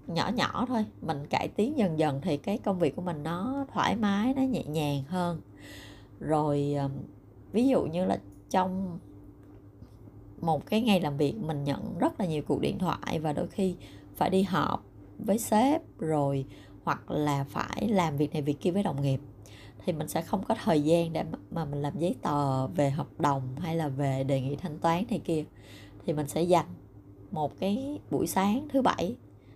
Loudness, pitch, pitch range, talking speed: -30 LUFS, 155 Hz, 135-190 Hz, 195 wpm